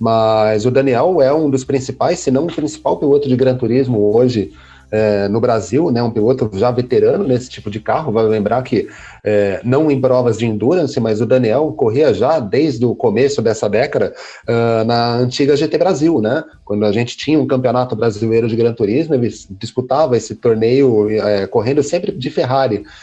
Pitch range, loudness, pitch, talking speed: 110-135 Hz, -15 LUFS, 120 Hz, 190 wpm